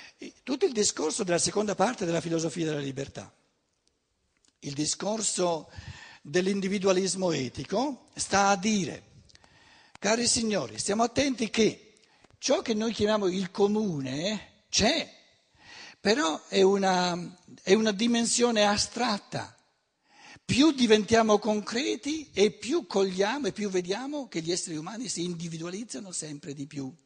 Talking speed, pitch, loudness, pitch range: 120 wpm, 200 Hz, -27 LUFS, 175-225 Hz